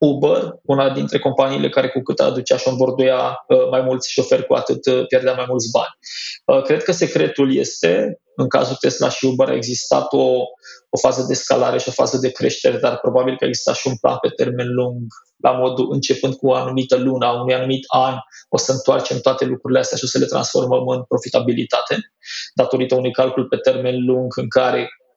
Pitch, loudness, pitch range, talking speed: 130 Hz, -18 LUFS, 125-130 Hz, 195 wpm